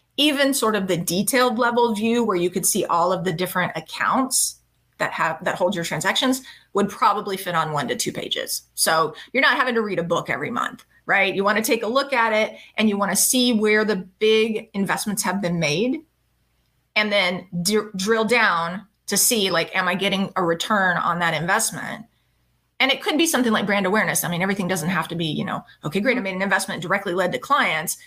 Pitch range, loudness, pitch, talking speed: 180-225 Hz, -21 LUFS, 200 Hz, 225 wpm